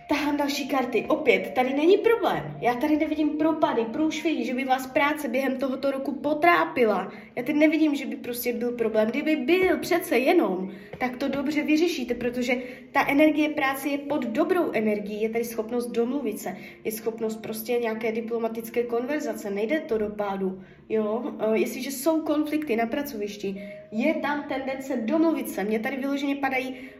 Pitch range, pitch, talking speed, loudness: 225-300 Hz, 260 Hz, 165 wpm, -25 LUFS